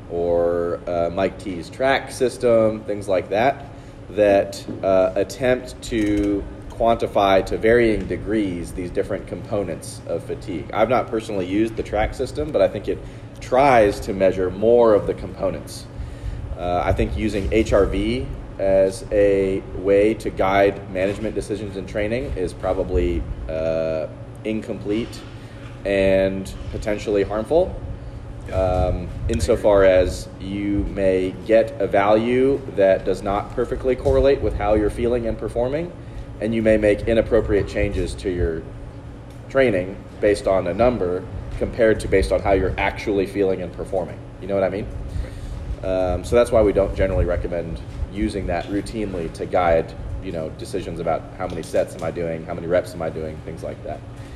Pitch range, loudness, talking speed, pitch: 95-110 Hz, -21 LUFS, 155 wpm, 100 Hz